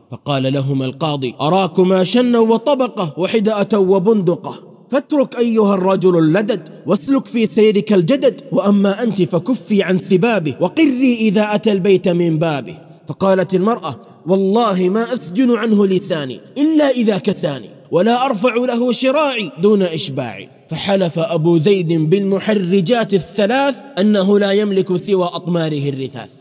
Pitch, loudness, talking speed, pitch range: 195 Hz, -15 LUFS, 125 wpm, 175-230 Hz